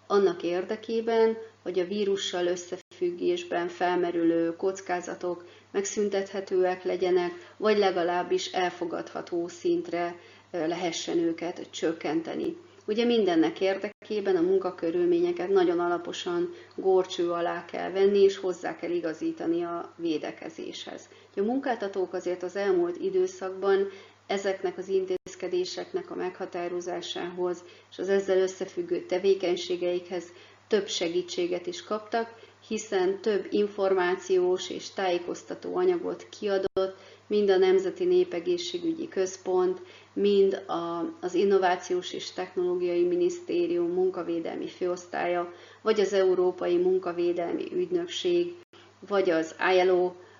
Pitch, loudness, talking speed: 195 Hz, -28 LUFS, 100 wpm